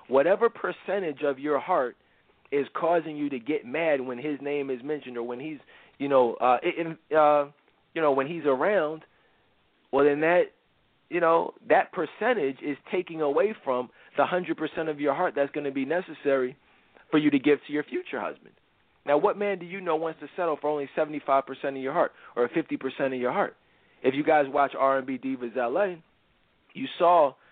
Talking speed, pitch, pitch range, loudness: 195 wpm, 145 Hz, 135-165 Hz, -27 LUFS